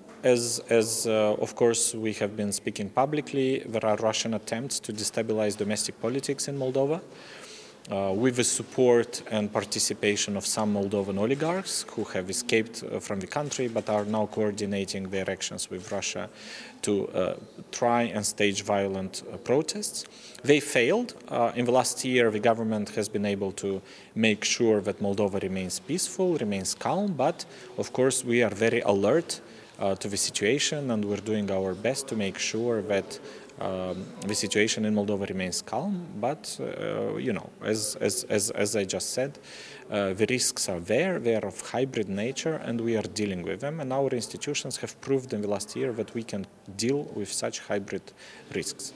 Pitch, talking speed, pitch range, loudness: 110 Hz, 175 wpm, 100-125 Hz, -28 LUFS